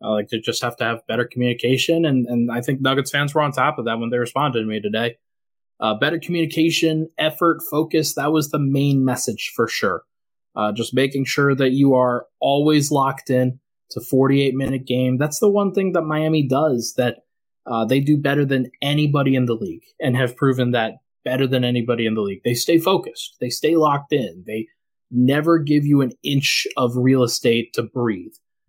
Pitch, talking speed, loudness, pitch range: 135 Hz, 205 wpm, -20 LUFS, 120-150 Hz